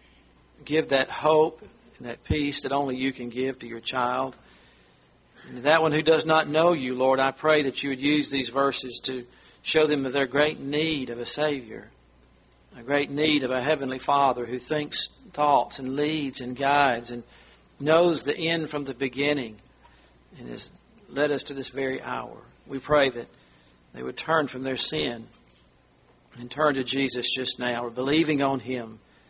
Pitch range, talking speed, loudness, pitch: 120-145 Hz, 180 wpm, -25 LUFS, 135 Hz